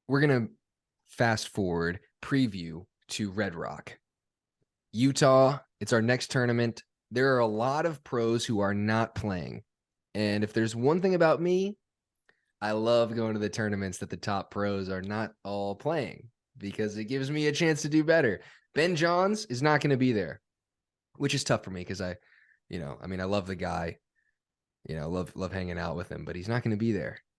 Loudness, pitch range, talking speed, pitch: -29 LUFS, 100-135 Hz, 195 wpm, 110 Hz